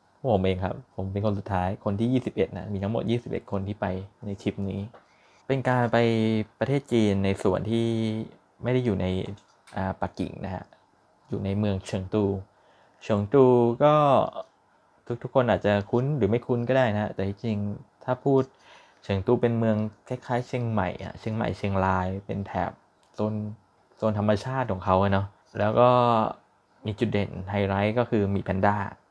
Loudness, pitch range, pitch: -26 LUFS, 100-120 Hz, 105 Hz